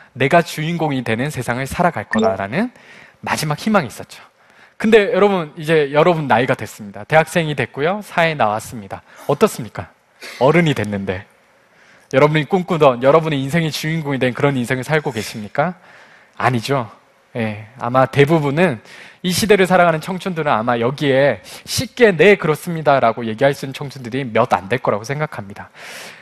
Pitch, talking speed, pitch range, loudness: 145 Hz, 355 characters per minute, 120-170 Hz, -17 LUFS